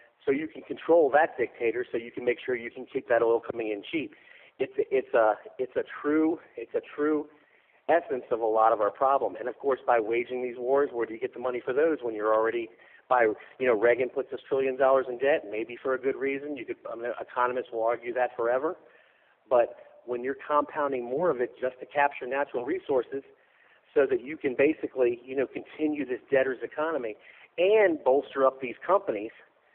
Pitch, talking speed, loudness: 140 Hz, 215 wpm, -28 LUFS